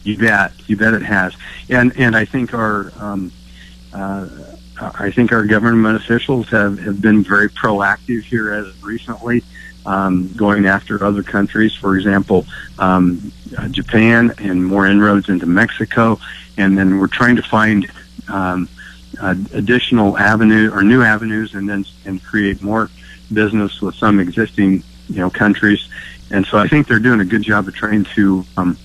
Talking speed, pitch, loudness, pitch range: 165 wpm, 105 Hz, -14 LUFS, 95-110 Hz